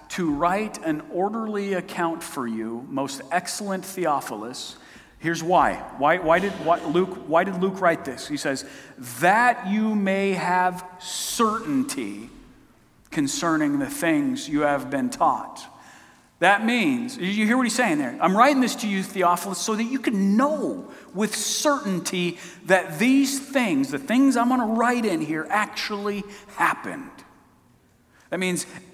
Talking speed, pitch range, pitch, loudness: 150 wpm, 180-250 Hz, 200 Hz, -23 LUFS